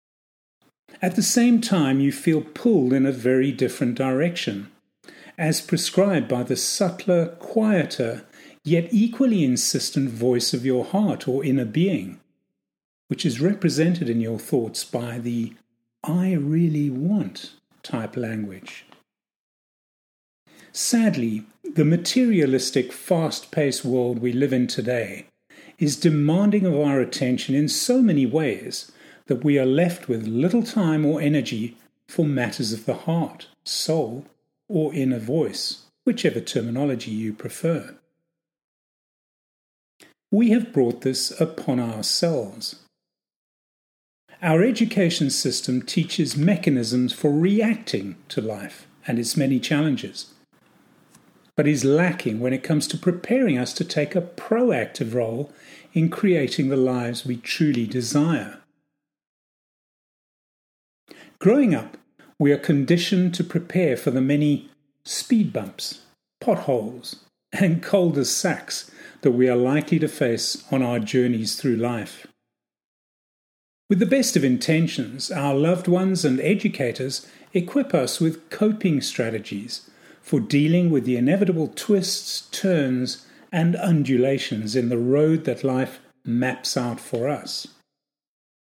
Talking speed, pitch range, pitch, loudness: 125 wpm, 125-175 Hz, 145 Hz, -22 LUFS